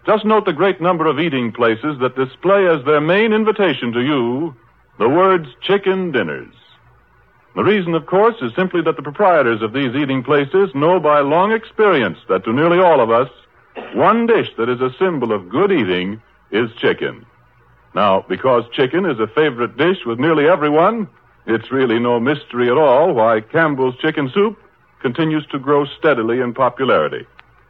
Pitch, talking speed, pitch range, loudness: 150 Hz, 175 wpm, 125-185 Hz, -16 LUFS